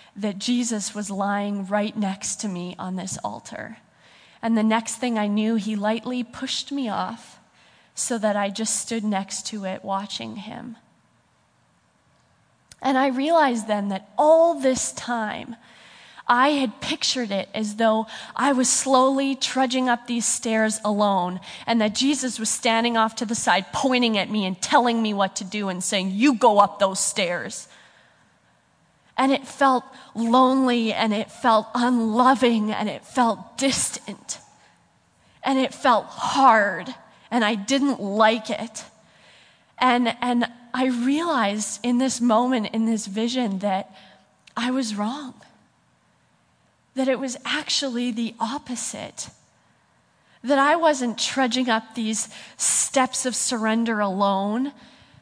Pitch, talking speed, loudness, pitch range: 230 Hz, 140 wpm, -22 LUFS, 210-255 Hz